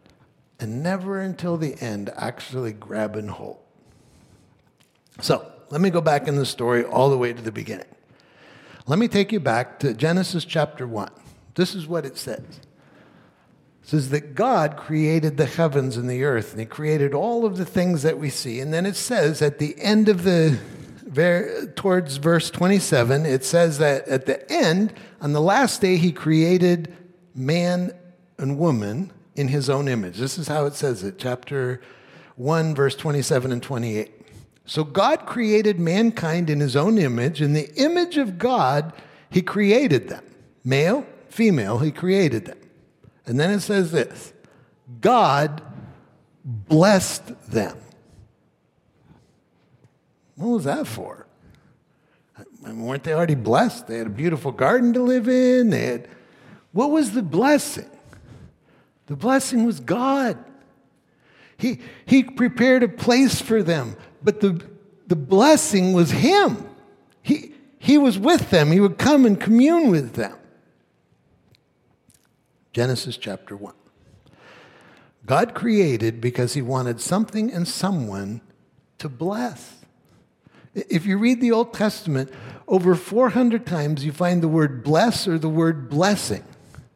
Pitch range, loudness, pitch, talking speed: 135-200 Hz, -21 LUFS, 165 Hz, 145 wpm